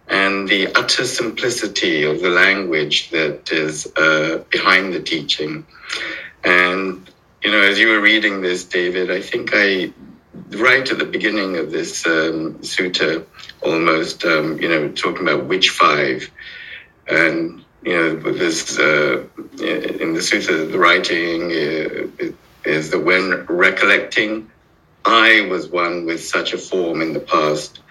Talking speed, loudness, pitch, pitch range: 140 wpm, -16 LUFS, 90 Hz, 80-100 Hz